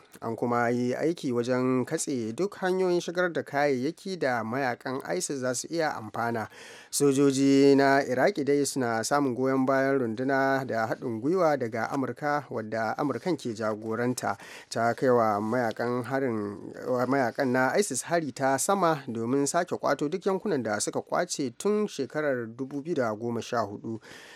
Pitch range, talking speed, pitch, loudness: 120-145 Hz, 140 wpm, 135 Hz, -27 LUFS